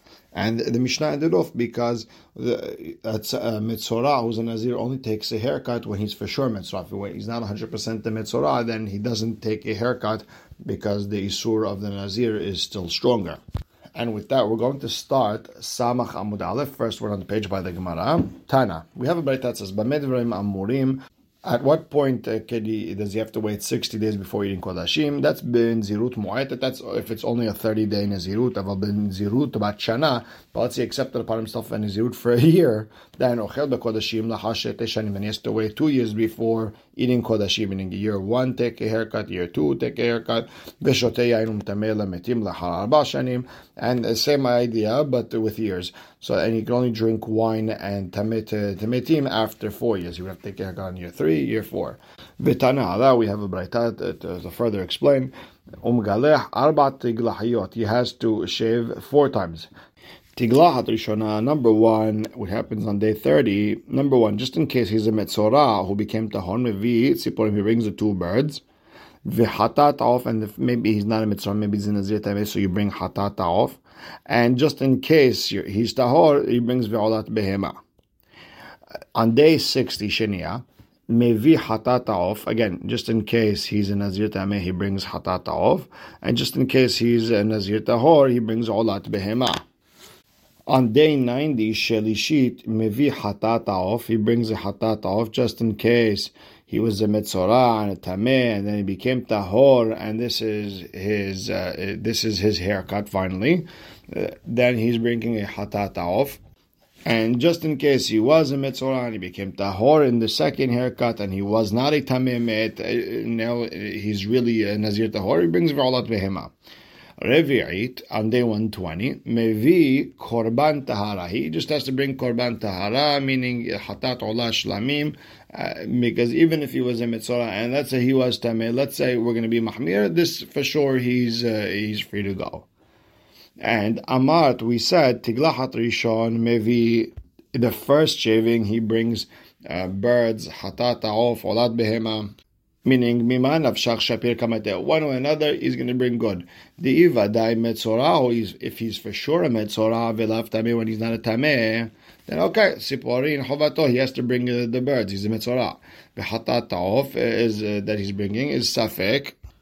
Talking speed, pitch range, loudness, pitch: 175 wpm, 105-125 Hz, -22 LUFS, 115 Hz